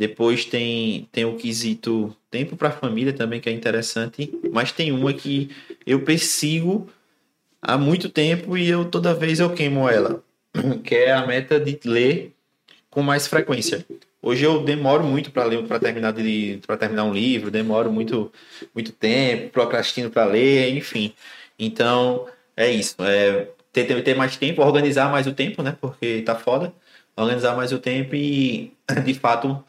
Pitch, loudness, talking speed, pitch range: 130 Hz, -21 LUFS, 160 wpm, 115-145 Hz